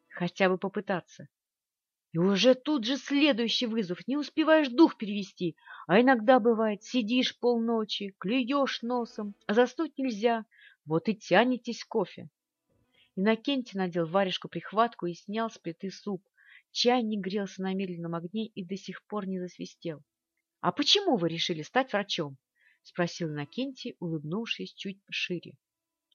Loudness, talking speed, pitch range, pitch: -29 LUFS, 135 wpm, 185-245 Hz, 210 Hz